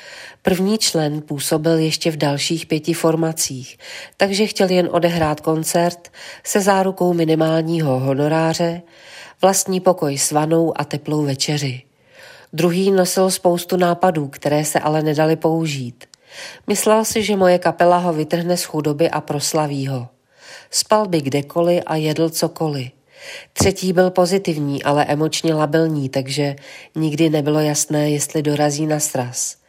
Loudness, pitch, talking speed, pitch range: -18 LUFS, 160 Hz, 130 wpm, 150-175 Hz